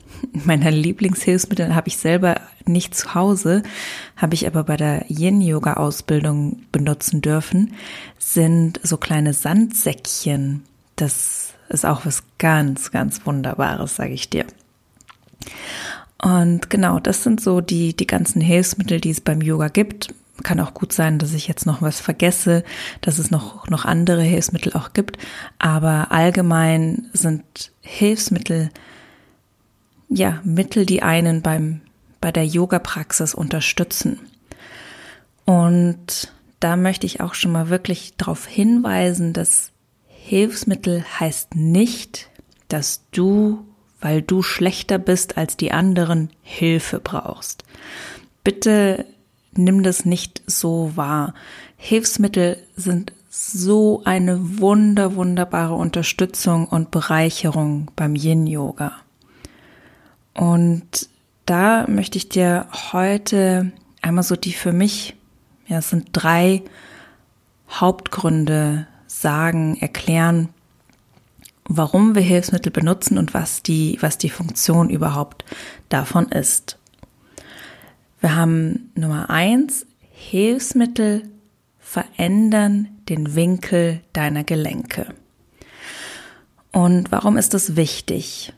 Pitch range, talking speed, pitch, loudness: 160-195 Hz, 110 wpm, 175 Hz, -19 LUFS